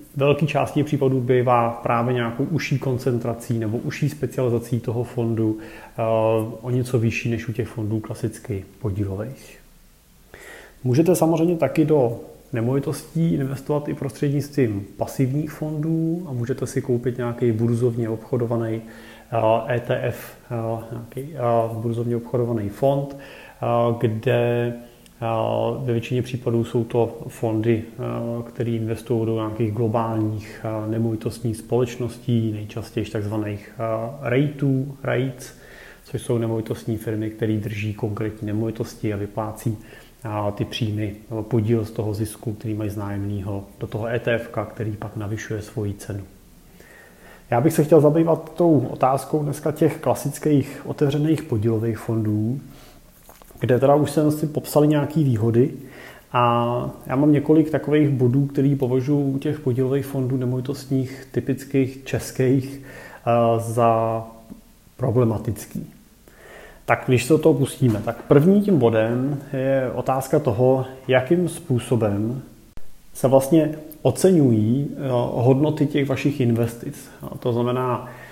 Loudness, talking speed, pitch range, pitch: -22 LUFS, 115 wpm, 115-135 Hz, 120 Hz